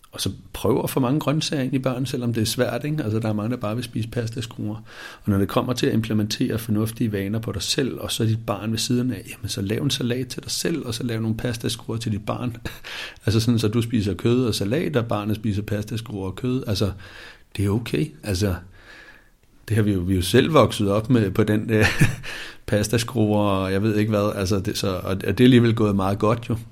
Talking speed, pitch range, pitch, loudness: 255 wpm, 105-120 Hz, 110 Hz, -23 LUFS